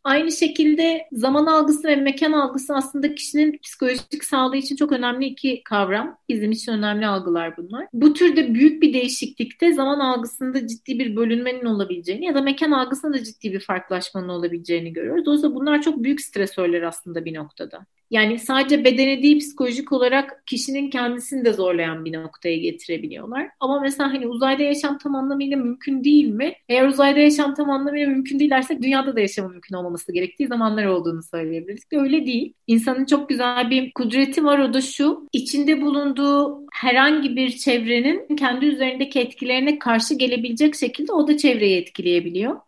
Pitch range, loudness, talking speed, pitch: 230-290 Hz, -20 LUFS, 165 wpm, 265 Hz